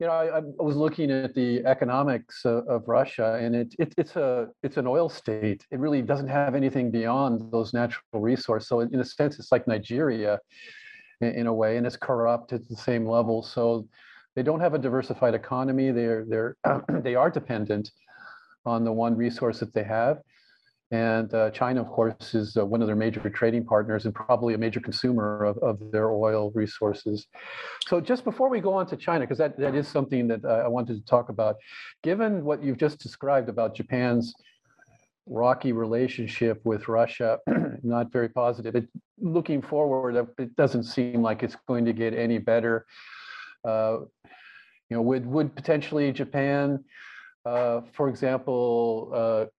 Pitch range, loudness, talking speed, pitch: 115-140 Hz, -26 LUFS, 180 wpm, 120 Hz